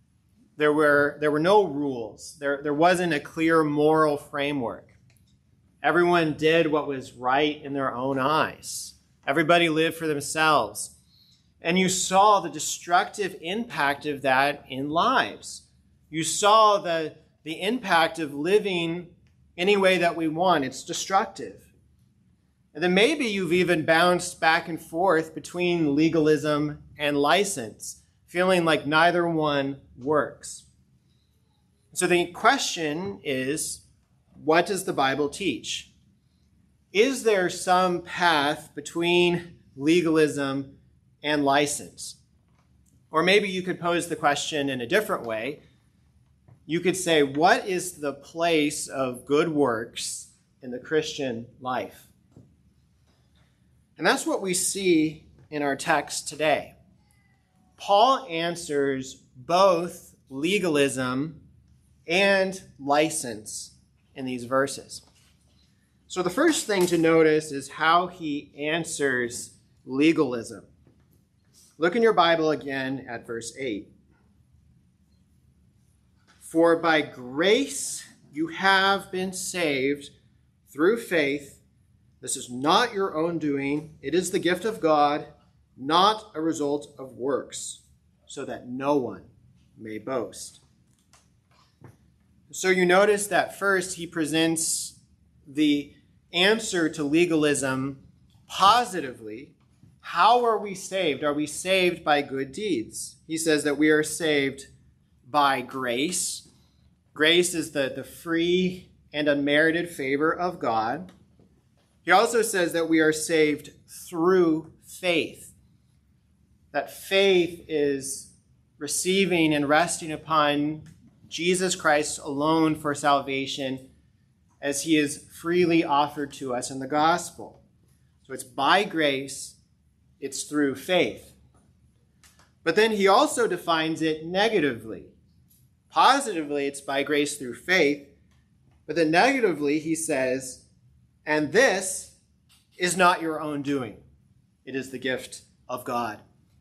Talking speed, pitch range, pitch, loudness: 120 wpm, 140-175 Hz, 155 Hz, -24 LUFS